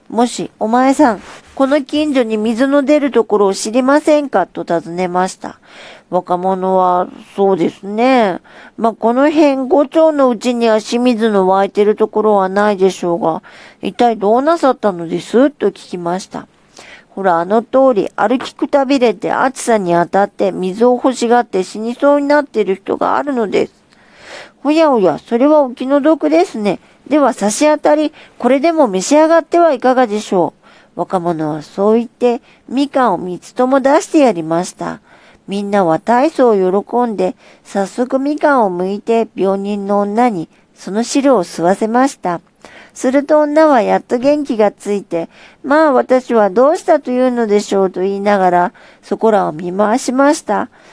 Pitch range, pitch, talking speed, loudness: 195-275 Hz, 230 Hz, 320 characters per minute, -14 LUFS